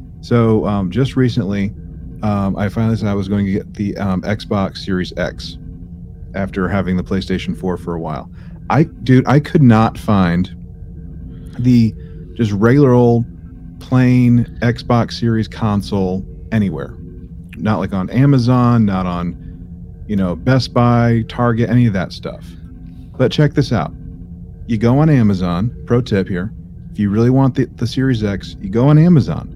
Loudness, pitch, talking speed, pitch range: -16 LUFS, 100 Hz, 160 wpm, 85-120 Hz